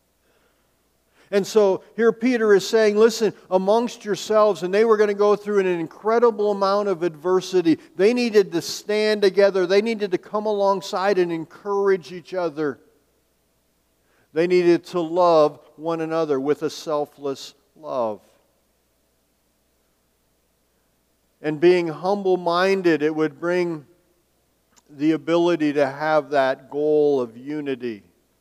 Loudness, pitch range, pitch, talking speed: -21 LUFS, 150-200 Hz, 175 Hz, 125 wpm